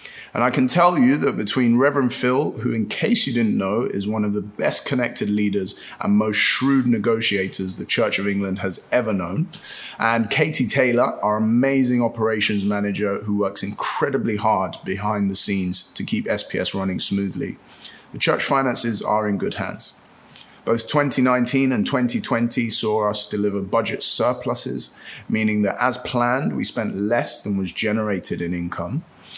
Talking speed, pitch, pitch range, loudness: 165 wpm, 110 Hz, 100-125 Hz, -20 LUFS